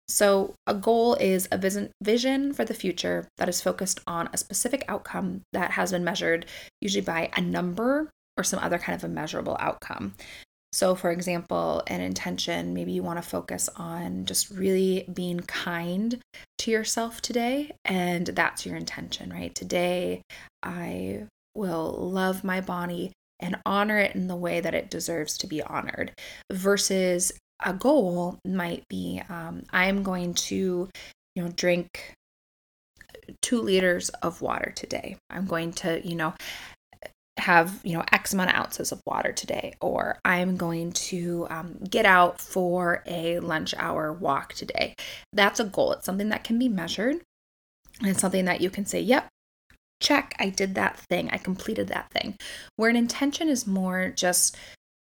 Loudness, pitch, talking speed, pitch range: -27 LUFS, 185 Hz, 160 wpm, 170-205 Hz